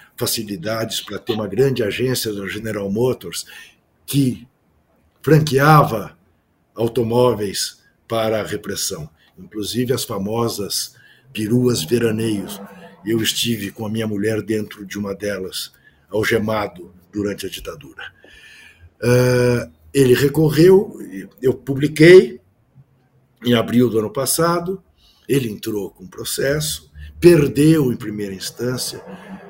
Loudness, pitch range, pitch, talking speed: -18 LUFS, 100-130 Hz, 115 Hz, 105 wpm